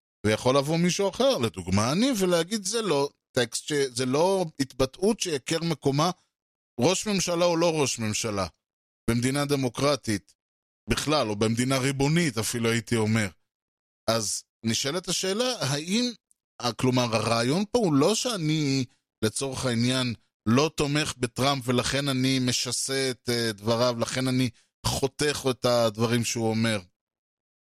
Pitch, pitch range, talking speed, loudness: 130 Hz, 115-150 Hz, 120 wpm, -26 LUFS